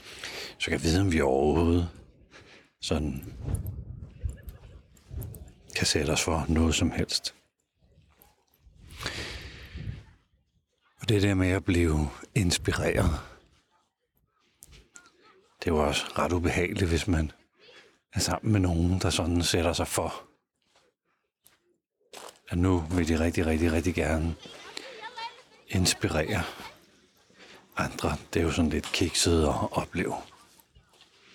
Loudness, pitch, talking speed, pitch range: -28 LUFS, 85 Hz, 105 wpm, 80-95 Hz